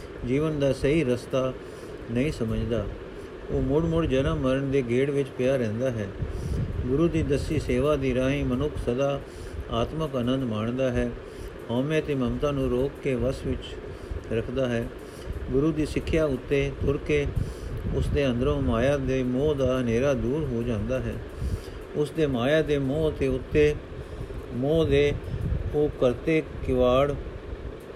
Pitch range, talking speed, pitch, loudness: 120-145 Hz, 150 wpm, 130 Hz, -26 LUFS